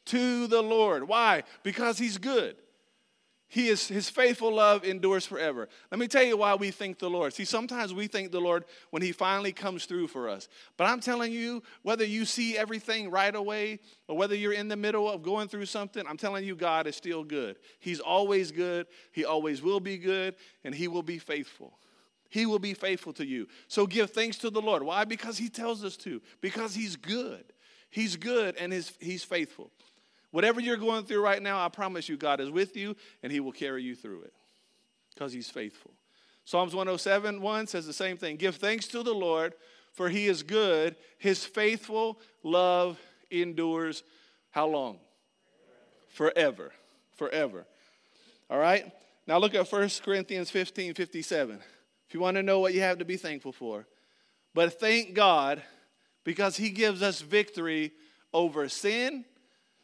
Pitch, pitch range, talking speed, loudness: 195 Hz, 175-220 Hz, 180 wpm, -30 LUFS